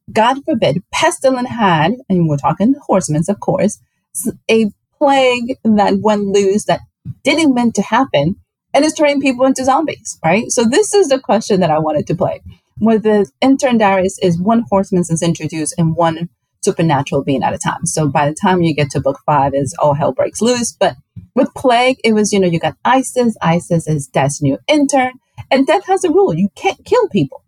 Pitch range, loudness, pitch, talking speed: 170-260 Hz, -14 LUFS, 205 Hz, 200 wpm